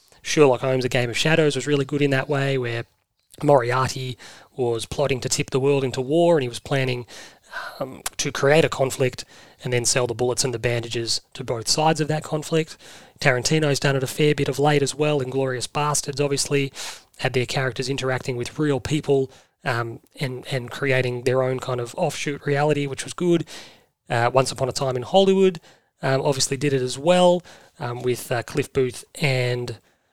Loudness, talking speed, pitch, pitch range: -22 LUFS, 195 wpm, 135 Hz, 125-145 Hz